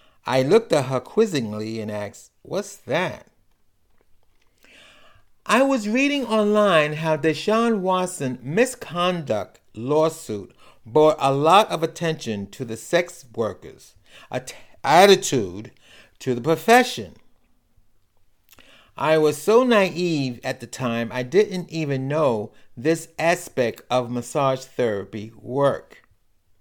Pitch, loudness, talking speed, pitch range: 150 Hz, -21 LUFS, 115 wpm, 120-175 Hz